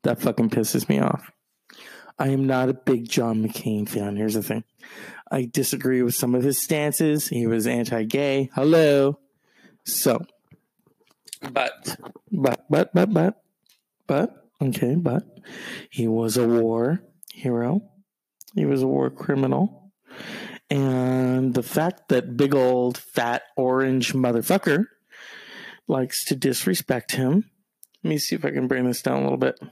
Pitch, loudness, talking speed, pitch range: 130 Hz, -23 LUFS, 145 wpm, 120-145 Hz